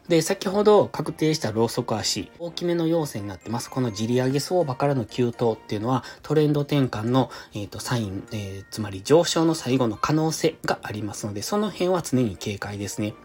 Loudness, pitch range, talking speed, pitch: -24 LUFS, 110-160 Hz, 405 characters per minute, 125 Hz